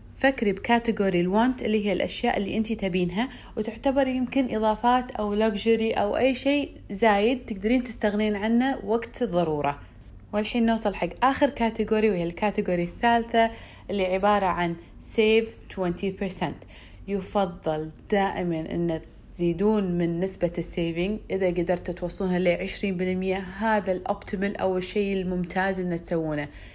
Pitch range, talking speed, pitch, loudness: 180-225 Hz, 125 wpm, 200 Hz, -26 LUFS